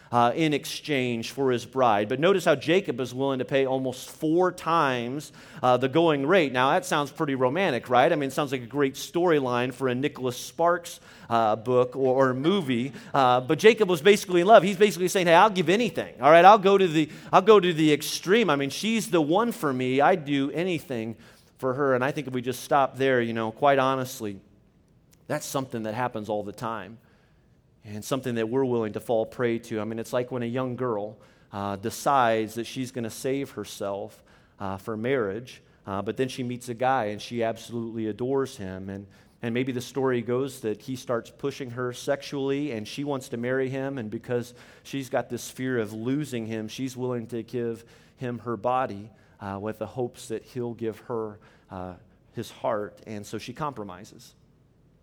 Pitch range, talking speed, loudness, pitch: 115-140 Hz, 205 wpm, -25 LUFS, 125 Hz